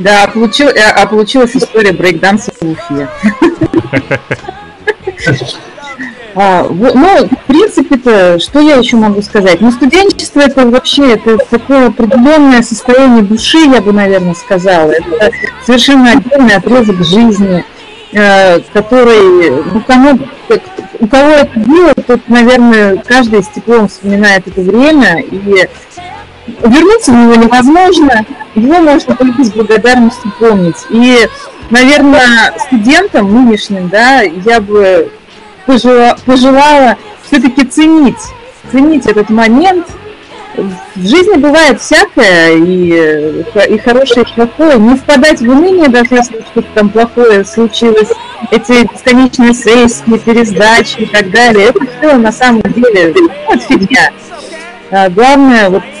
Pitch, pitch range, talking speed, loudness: 240 Hz, 210-275 Hz, 115 wpm, -6 LUFS